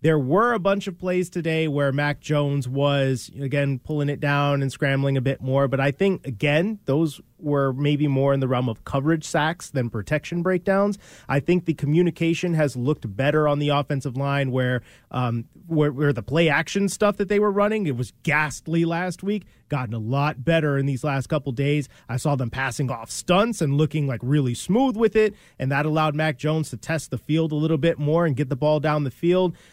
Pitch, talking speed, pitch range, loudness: 150 Hz, 215 wpm, 135-165 Hz, -23 LUFS